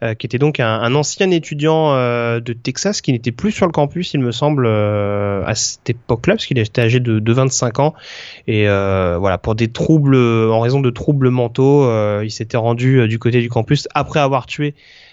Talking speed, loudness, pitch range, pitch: 220 wpm, -16 LUFS, 115-145 Hz, 125 Hz